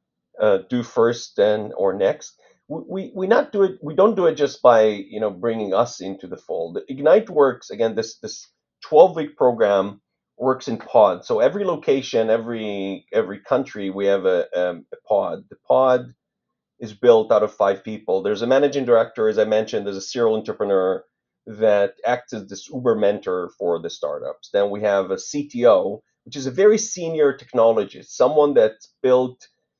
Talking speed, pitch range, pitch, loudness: 180 wpm, 105-160 Hz, 120 Hz, -20 LUFS